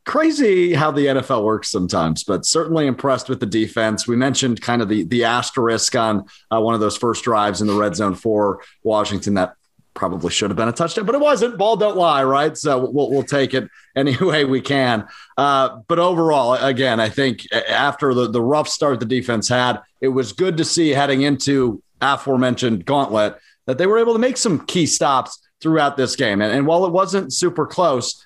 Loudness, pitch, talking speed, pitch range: -18 LUFS, 130 Hz, 205 wpm, 115-155 Hz